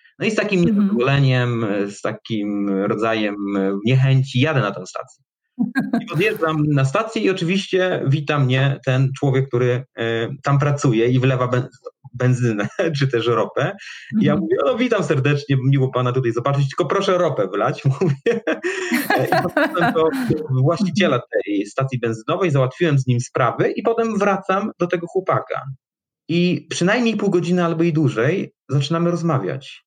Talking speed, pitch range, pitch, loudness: 145 wpm, 125-180 Hz, 140 Hz, -19 LUFS